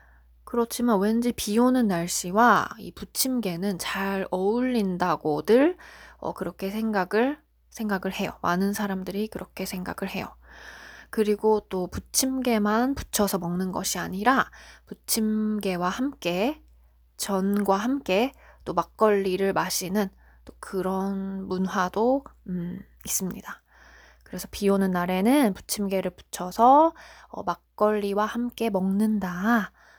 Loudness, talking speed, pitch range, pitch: -25 LUFS, 245 characters per minute, 185-225 Hz, 200 Hz